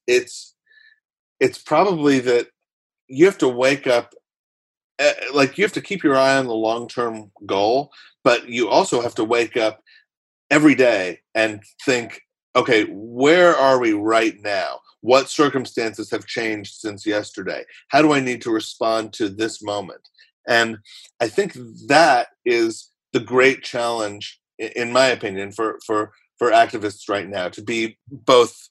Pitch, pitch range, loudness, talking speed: 120 Hz, 110-170 Hz, -19 LUFS, 155 wpm